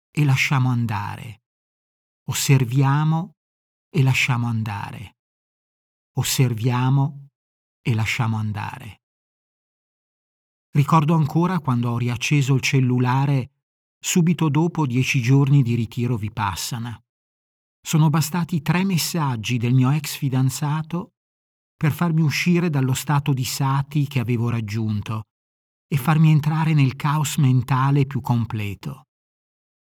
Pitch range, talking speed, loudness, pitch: 115-150 Hz, 105 wpm, -21 LUFS, 130 Hz